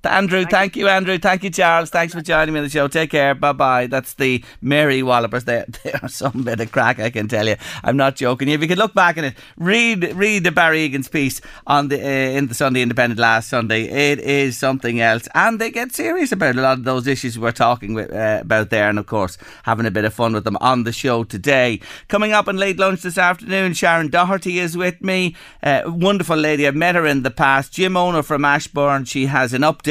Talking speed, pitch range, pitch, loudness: 240 wpm, 125-175 Hz, 140 Hz, -17 LUFS